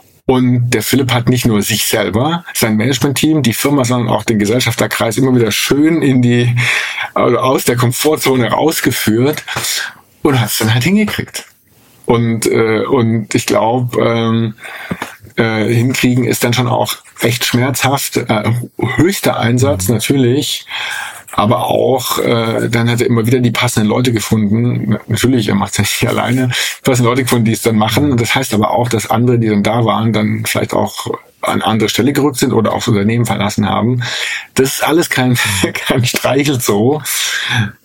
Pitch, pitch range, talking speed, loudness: 120 Hz, 110-130 Hz, 170 wpm, -13 LUFS